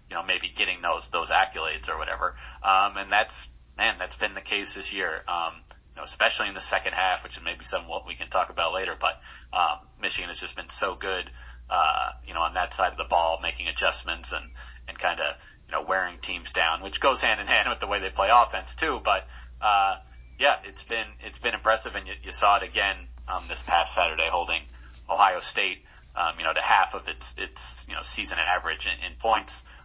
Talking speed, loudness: 225 wpm, -26 LUFS